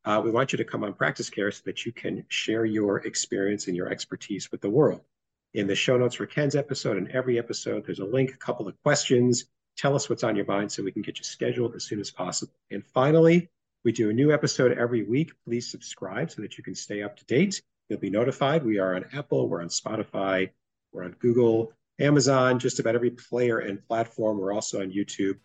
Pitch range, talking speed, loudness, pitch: 100-135 Hz, 230 wpm, -26 LUFS, 120 Hz